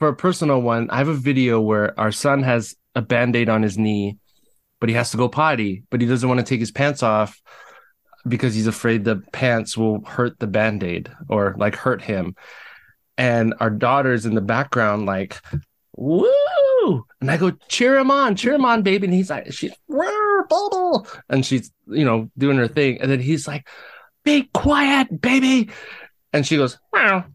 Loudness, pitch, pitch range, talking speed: -19 LUFS, 125 Hz, 110-165 Hz, 195 wpm